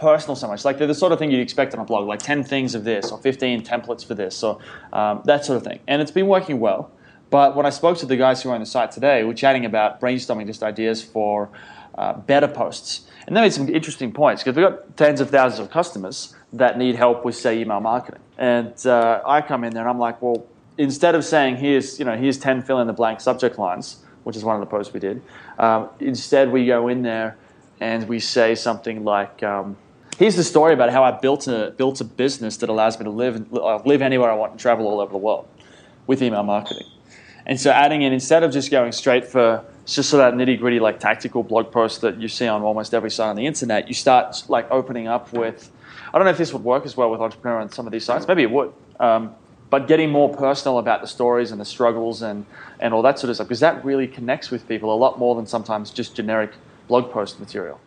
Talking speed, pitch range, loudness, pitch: 250 wpm, 115-135 Hz, -20 LUFS, 120 Hz